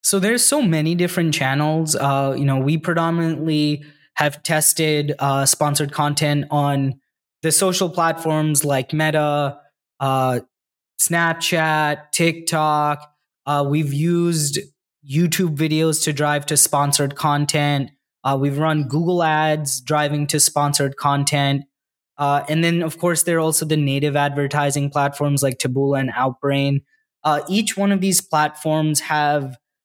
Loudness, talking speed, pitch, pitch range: -19 LUFS, 135 wpm, 150 Hz, 145-160 Hz